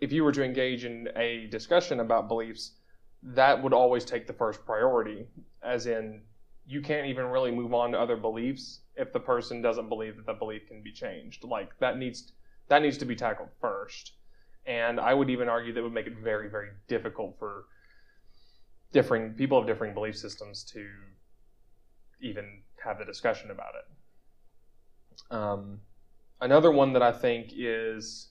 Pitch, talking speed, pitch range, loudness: 115 Hz, 170 wpm, 110-130 Hz, -29 LUFS